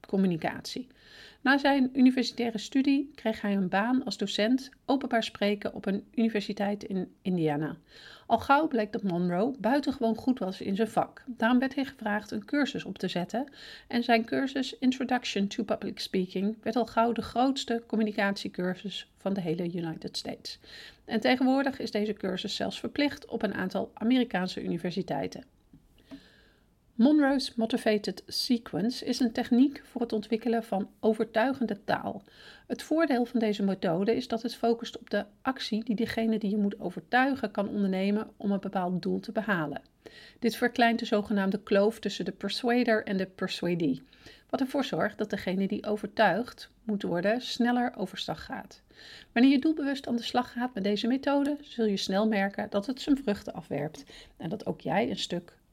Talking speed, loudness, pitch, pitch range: 165 wpm, -29 LUFS, 225 Hz, 200-245 Hz